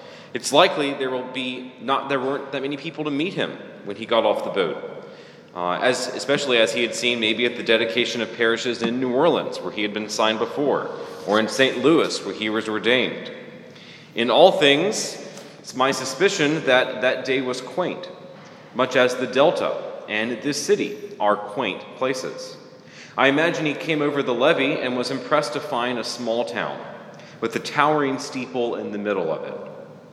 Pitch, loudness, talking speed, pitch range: 130 Hz, -22 LUFS, 190 wpm, 120-165 Hz